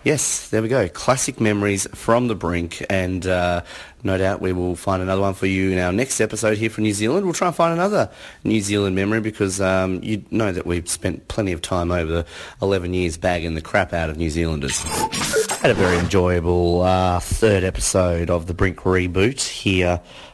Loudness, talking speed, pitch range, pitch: -20 LUFS, 205 wpm, 90-105 Hz, 95 Hz